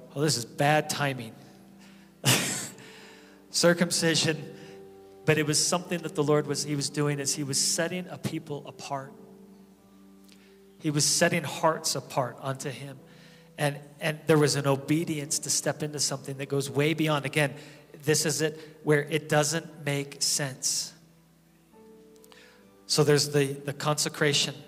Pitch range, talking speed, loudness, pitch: 140-160 Hz, 145 wpm, -27 LUFS, 150 Hz